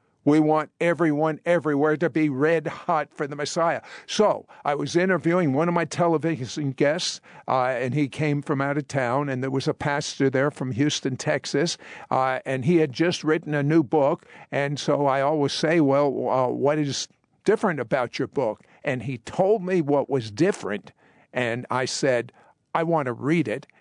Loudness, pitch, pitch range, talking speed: -24 LUFS, 150 Hz, 135-160 Hz, 185 wpm